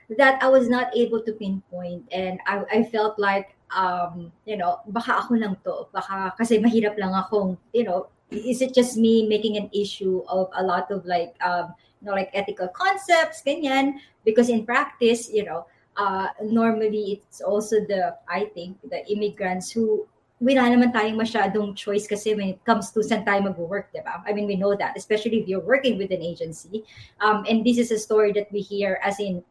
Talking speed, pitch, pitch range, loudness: 195 wpm, 210 Hz, 190-225 Hz, -23 LUFS